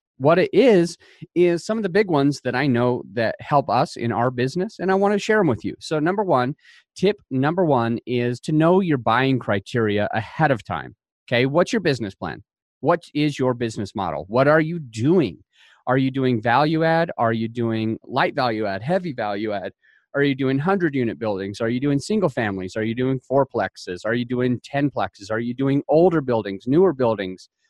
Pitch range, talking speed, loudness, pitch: 115-160 Hz, 210 wpm, -21 LUFS, 130 Hz